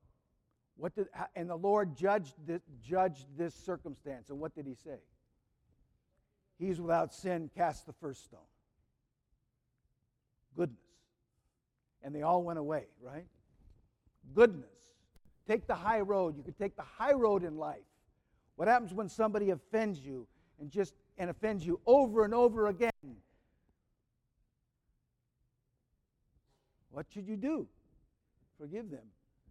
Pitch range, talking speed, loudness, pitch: 140-205 Hz, 130 wpm, -34 LUFS, 170 Hz